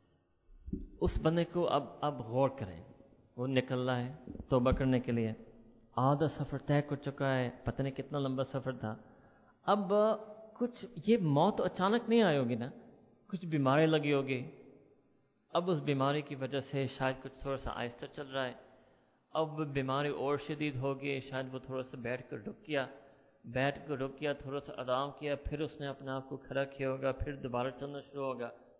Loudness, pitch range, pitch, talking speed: -35 LUFS, 130-145 Hz, 135 Hz, 185 wpm